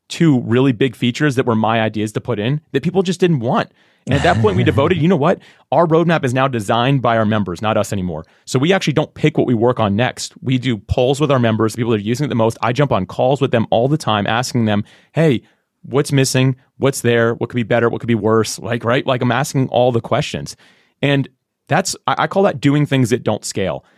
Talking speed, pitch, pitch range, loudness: 255 wpm, 125 Hz, 110-140 Hz, -16 LUFS